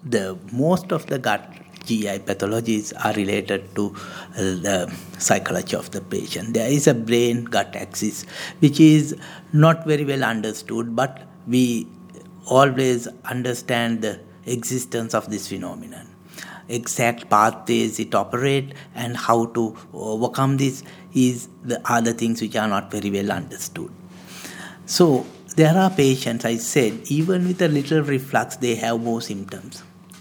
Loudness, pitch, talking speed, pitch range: -21 LUFS, 120 Hz, 140 wpm, 105-140 Hz